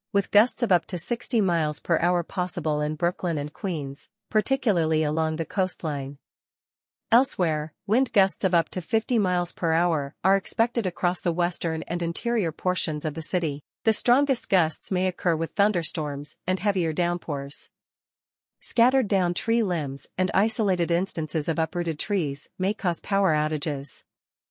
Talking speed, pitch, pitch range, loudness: 155 wpm, 175 Hz, 160-200 Hz, -25 LUFS